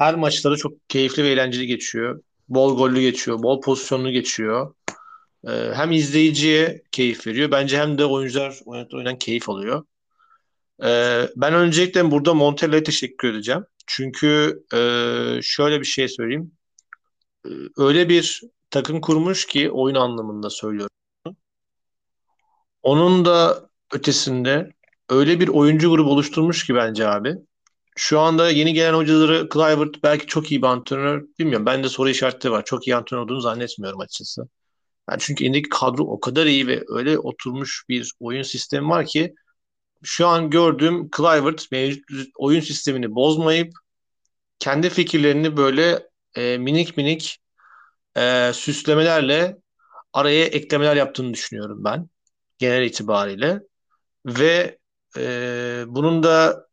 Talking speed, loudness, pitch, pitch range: 130 wpm, -19 LUFS, 145 Hz, 125-160 Hz